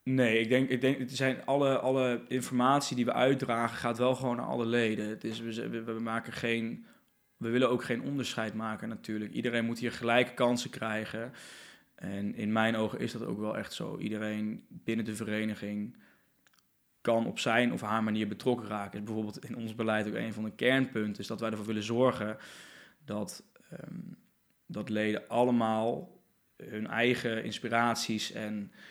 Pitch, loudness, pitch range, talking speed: 115 Hz, -32 LUFS, 110-125 Hz, 175 wpm